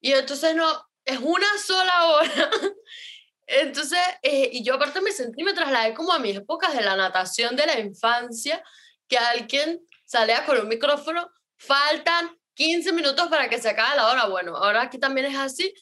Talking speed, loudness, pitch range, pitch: 180 wpm, -22 LUFS, 260-340 Hz, 295 Hz